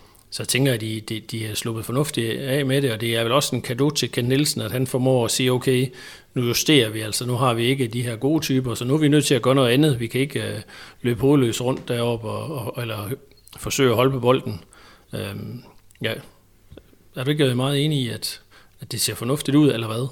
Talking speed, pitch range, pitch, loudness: 245 wpm, 115-135 Hz, 125 Hz, -22 LUFS